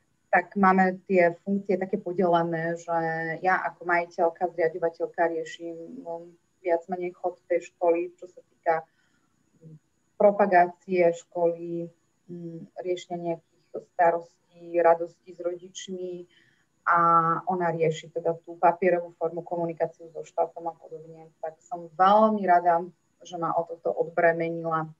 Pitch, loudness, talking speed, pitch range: 170 Hz, -26 LUFS, 120 wpm, 165-180 Hz